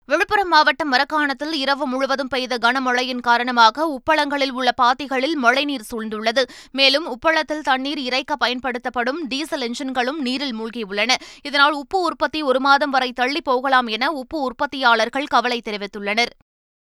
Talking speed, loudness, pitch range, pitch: 125 wpm, -19 LUFS, 245-295 Hz, 265 Hz